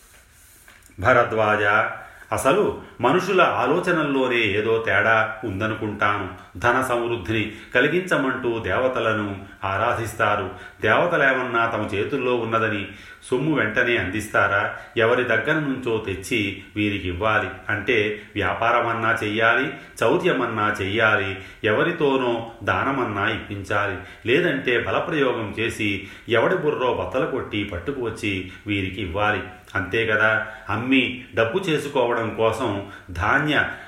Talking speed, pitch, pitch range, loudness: 90 wpm, 110 Hz, 100-120 Hz, -22 LUFS